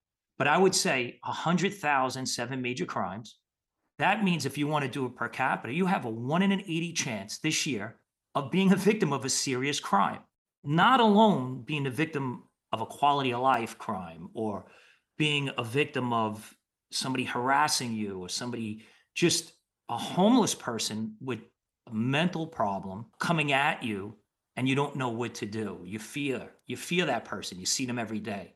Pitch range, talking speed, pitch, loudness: 120-160 Hz, 180 wpm, 135 Hz, -29 LUFS